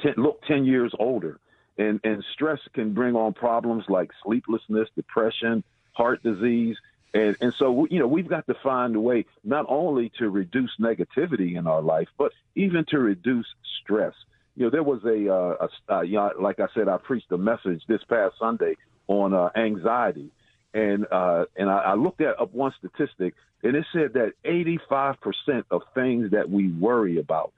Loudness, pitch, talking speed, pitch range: -25 LUFS, 115 Hz, 190 wpm, 100-125 Hz